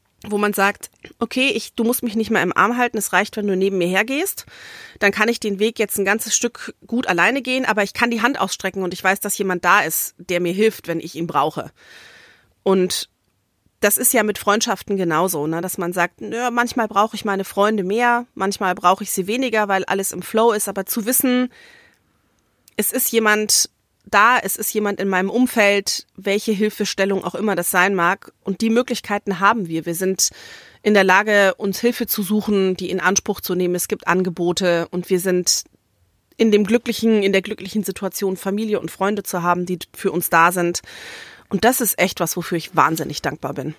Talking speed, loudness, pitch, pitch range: 210 wpm, -19 LUFS, 200 Hz, 185-225 Hz